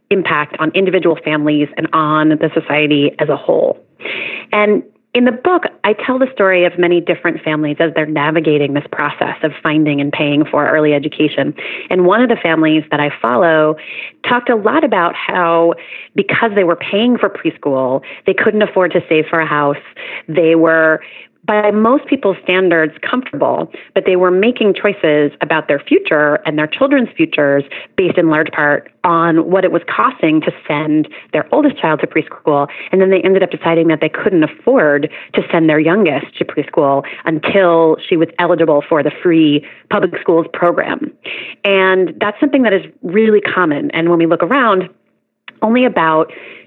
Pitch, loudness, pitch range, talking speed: 165 Hz, -13 LUFS, 155-195 Hz, 175 wpm